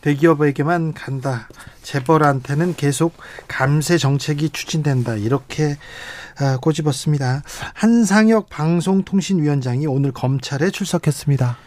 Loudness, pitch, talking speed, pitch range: -19 LUFS, 150 Hz, 285 characters per minute, 140-165 Hz